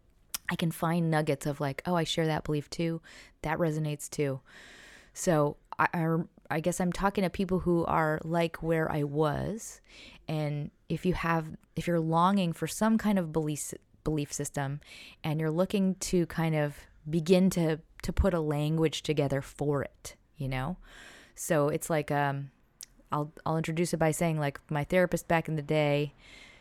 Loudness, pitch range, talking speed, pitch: -30 LUFS, 150-170 Hz, 175 wpm, 160 Hz